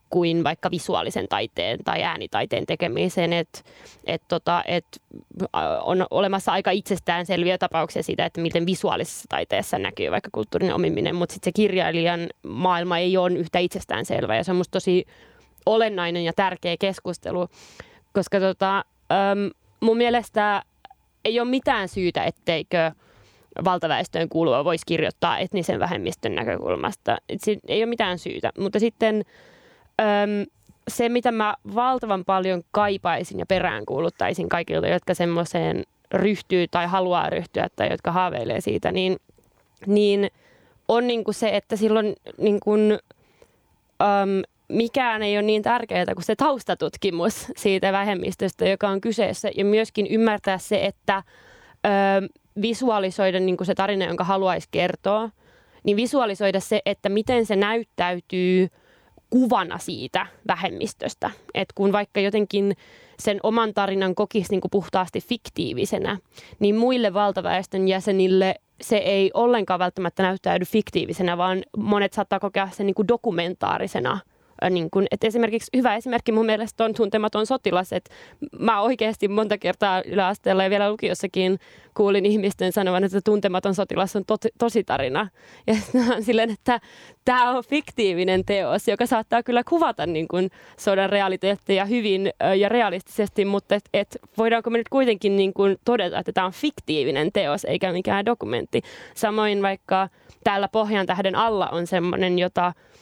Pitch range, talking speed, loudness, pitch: 185-220 Hz, 135 wpm, -23 LUFS, 200 Hz